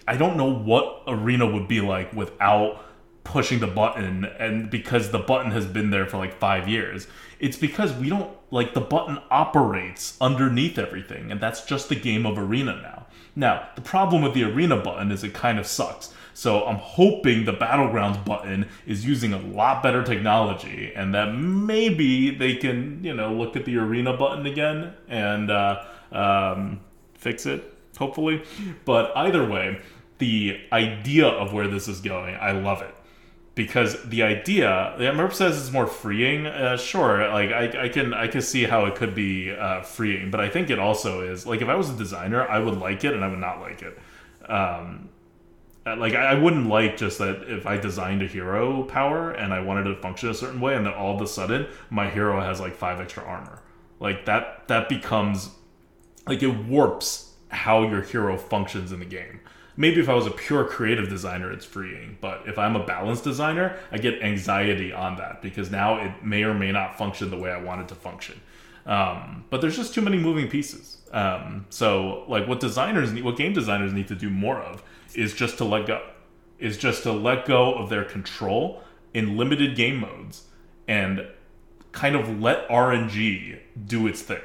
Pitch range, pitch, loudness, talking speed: 100-130 Hz, 110 Hz, -24 LUFS, 195 wpm